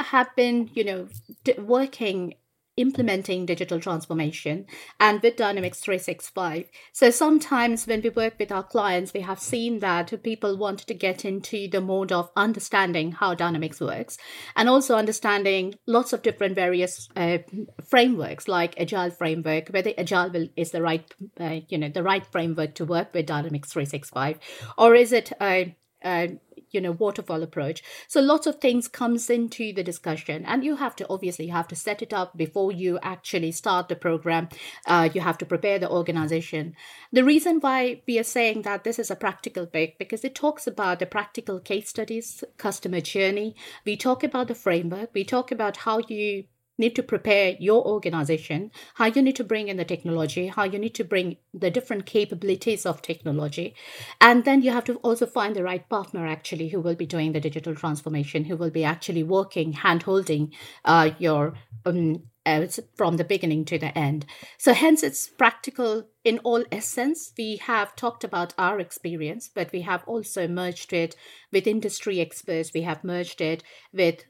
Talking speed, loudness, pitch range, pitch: 185 wpm, -25 LUFS, 170-225 Hz, 190 Hz